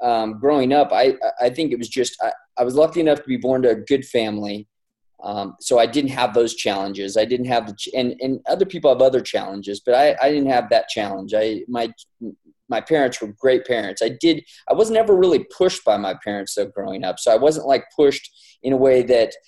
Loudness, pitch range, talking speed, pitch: -19 LUFS, 110-145 Hz, 235 wpm, 125 Hz